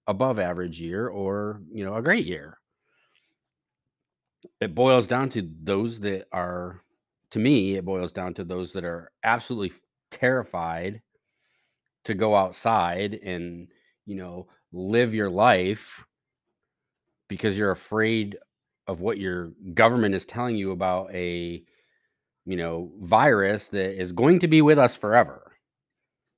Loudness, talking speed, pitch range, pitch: -24 LUFS, 135 wpm, 90-110 Hz, 95 Hz